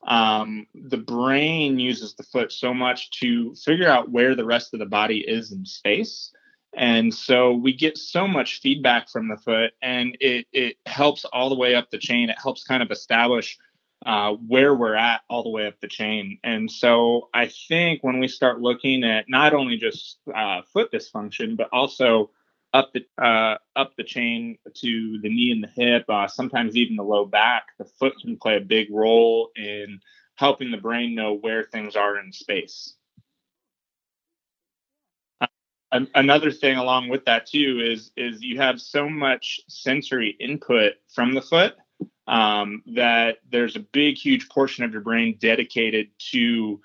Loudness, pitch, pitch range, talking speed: -21 LUFS, 125 Hz, 115-140 Hz, 175 wpm